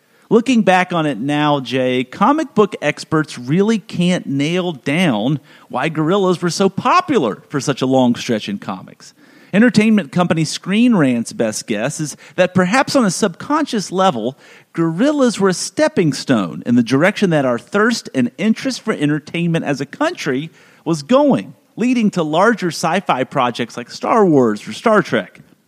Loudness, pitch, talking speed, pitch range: -16 LUFS, 180 Hz, 165 wpm, 150-220 Hz